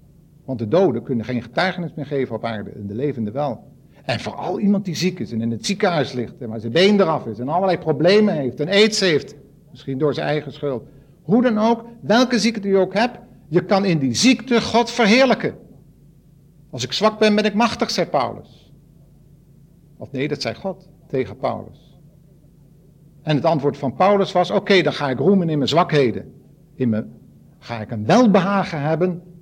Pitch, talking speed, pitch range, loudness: 155 Hz, 195 wpm, 140-195 Hz, -19 LUFS